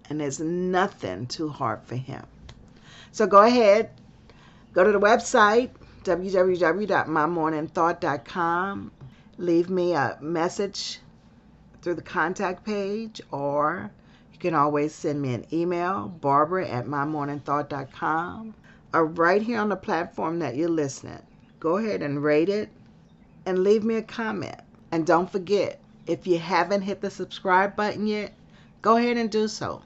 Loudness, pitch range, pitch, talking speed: -24 LUFS, 150-200 Hz, 175 Hz, 140 wpm